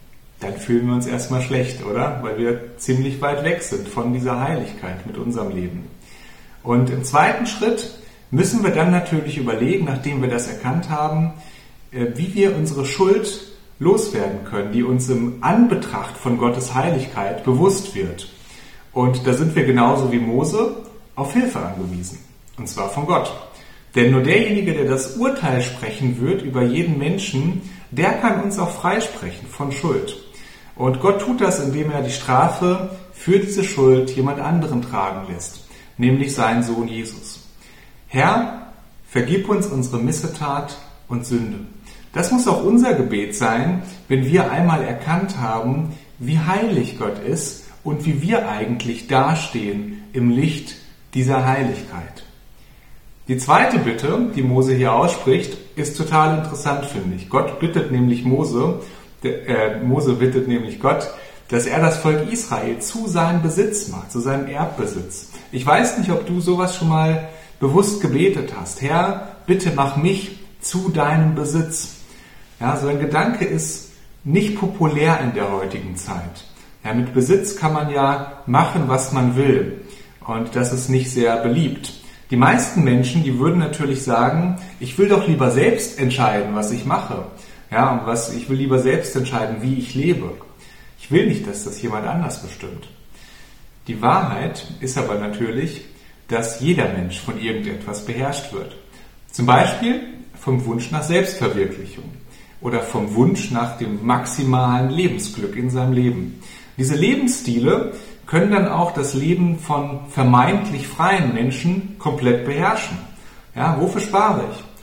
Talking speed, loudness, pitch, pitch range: 150 wpm, -19 LUFS, 135 Hz, 120-175 Hz